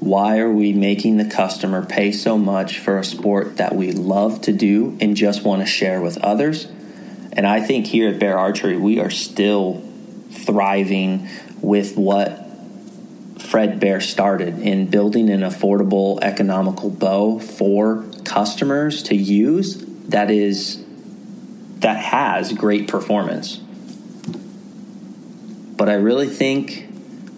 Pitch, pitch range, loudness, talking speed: 105 Hz, 100-140 Hz, -18 LUFS, 130 wpm